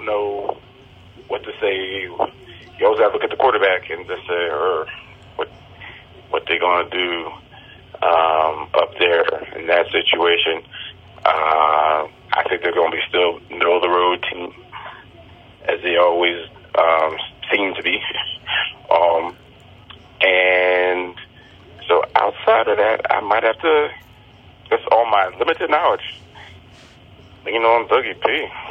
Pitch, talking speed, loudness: 90 Hz, 140 wpm, -18 LUFS